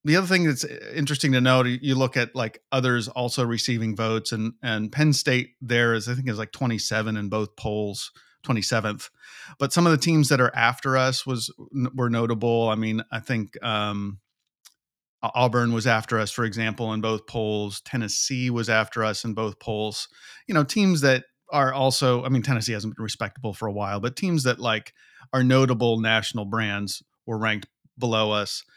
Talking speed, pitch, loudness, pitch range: 190 wpm, 115 Hz, -24 LUFS, 110-130 Hz